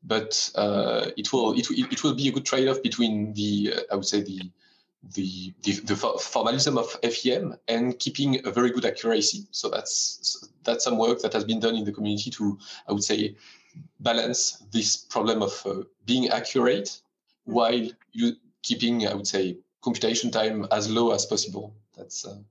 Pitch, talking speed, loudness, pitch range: 115 Hz, 185 wpm, -26 LUFS, 105-135 Hz